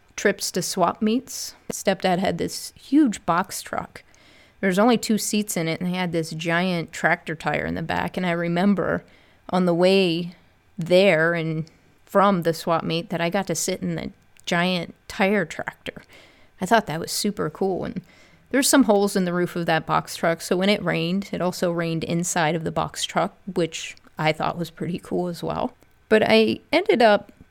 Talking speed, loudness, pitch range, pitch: 195 wpm, -23 LUFS, 170-205 Hz, 180 Hz